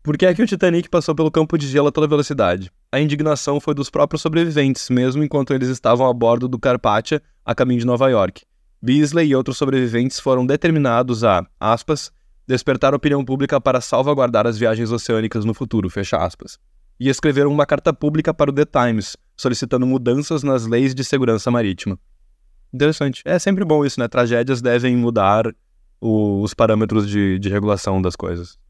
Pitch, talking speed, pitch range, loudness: 130 Hz, 180 wpm, 115-145 Hz, -18 LUFS